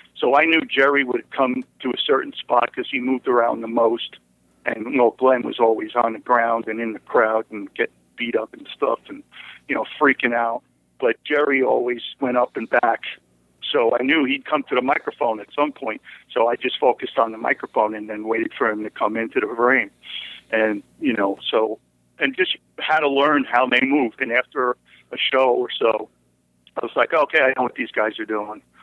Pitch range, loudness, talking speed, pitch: 110-135 Hz, -21 LUFS, 215 wpm, 115 Hz